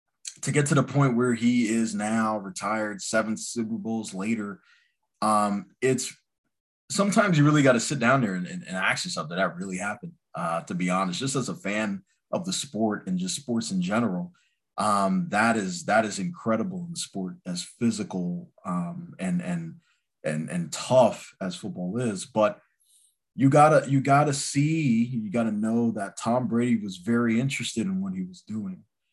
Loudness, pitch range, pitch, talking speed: -26 LUFS, 110-170 Hz, 120 Hz, 185 wpm